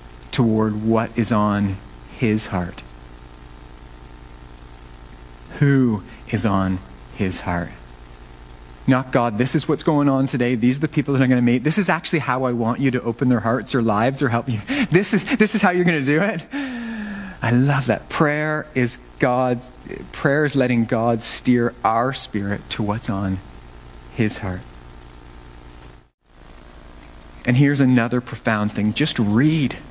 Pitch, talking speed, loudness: 115 Hz, 160 wpm, -20 LUFS